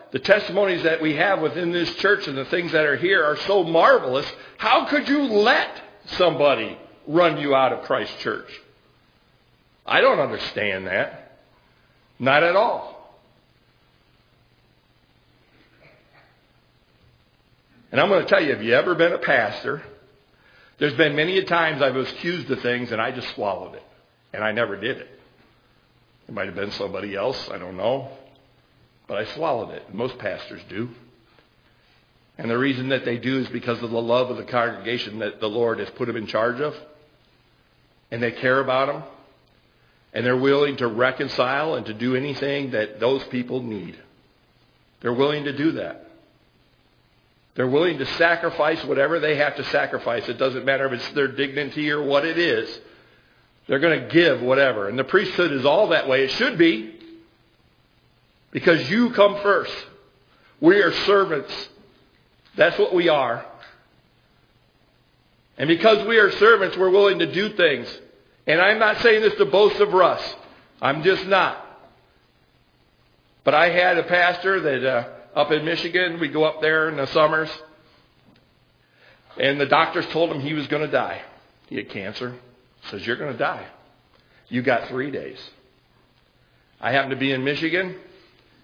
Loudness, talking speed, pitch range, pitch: -21 LUFS, 165 wpm, 125-170 Hz, 145 Hz